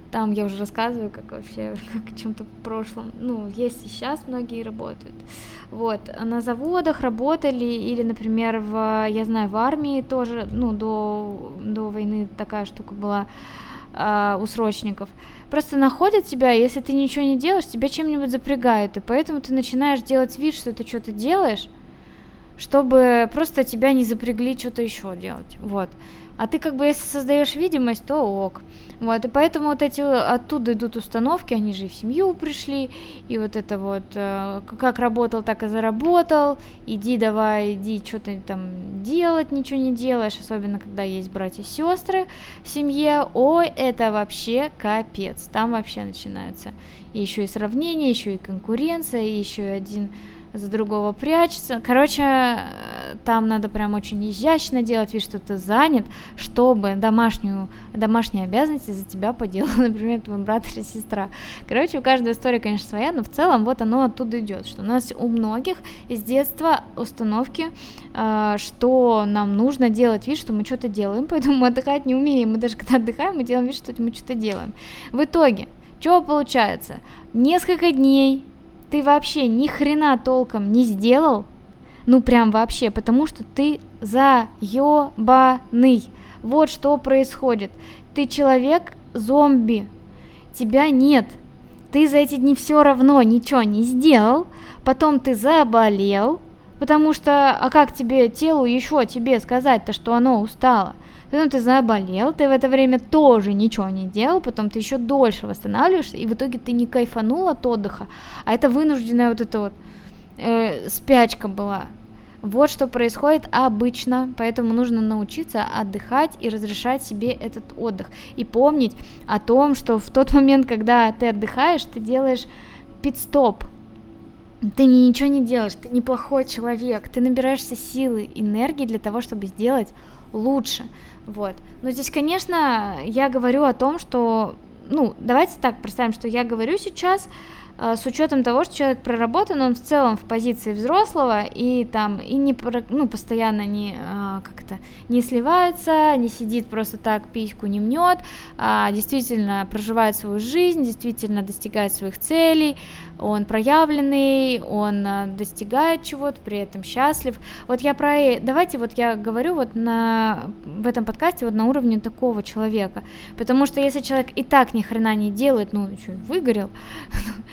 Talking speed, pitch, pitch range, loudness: 155 wpm, 240 Hz, 215-275 Hz, -20 LUFS